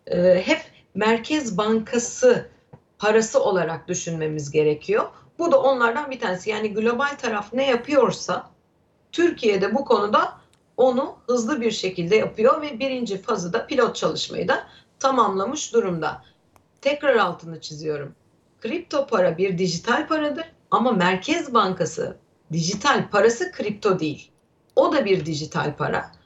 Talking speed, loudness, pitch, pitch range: 125 wpm, -22 LUFS, 225 Hz, 180-270 Hz